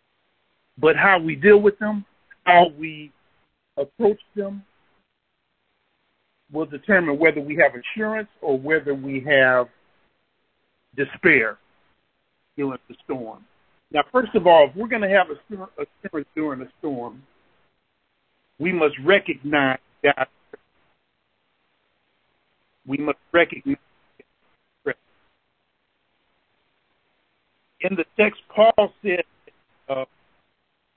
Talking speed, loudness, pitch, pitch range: 100 wpm, -20 LUFS, 165 Hz, 145-205 Hz